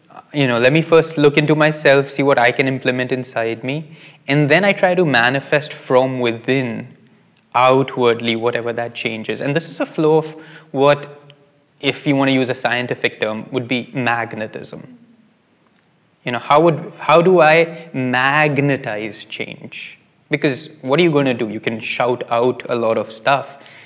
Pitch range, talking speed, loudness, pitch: 125-155 Hz, 175 wpm, -17 LUFS, 140 Hz